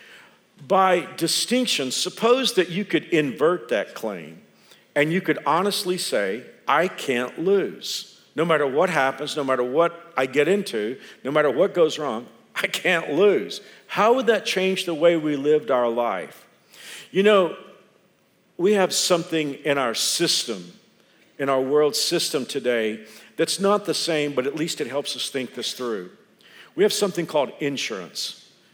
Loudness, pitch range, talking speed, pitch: -22 LUFS, 145-190 Hz, 160 wpm, 165 Hz